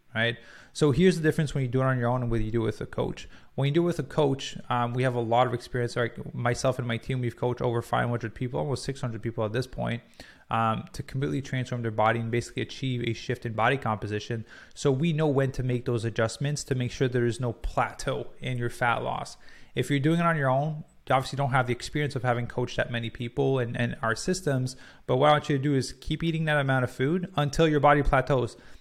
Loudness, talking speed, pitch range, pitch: -28 LUFS, 260 wpm, 120-140 Hz, 130 Hz